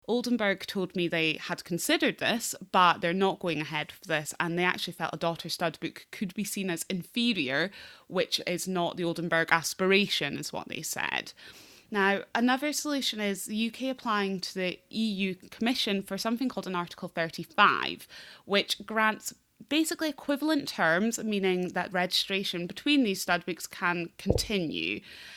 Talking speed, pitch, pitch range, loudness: 160 wpm, 195 Hz, 175-225 Hz, -29 LUFS